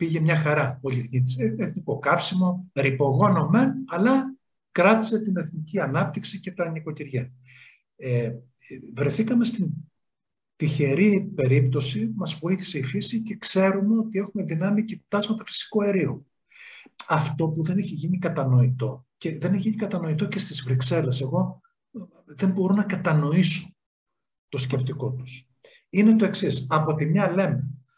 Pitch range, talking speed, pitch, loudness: 140-195 Hz, 140 wpm, 170 Hz, -24 LUFS